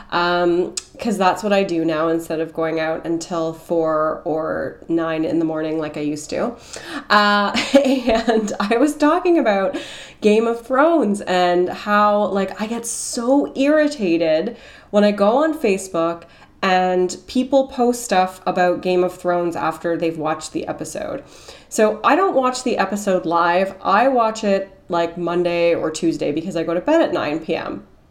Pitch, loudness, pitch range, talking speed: 190 Hz, -19 LUFS, 170-235 Hz, 165 wpm